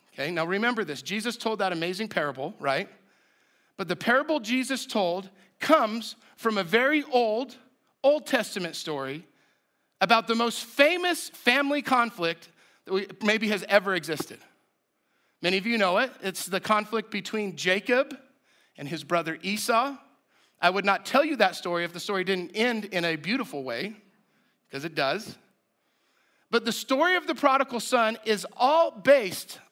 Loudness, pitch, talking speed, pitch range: -26 LUFS, 220 Hz, 155 wpm, 190-255 Hz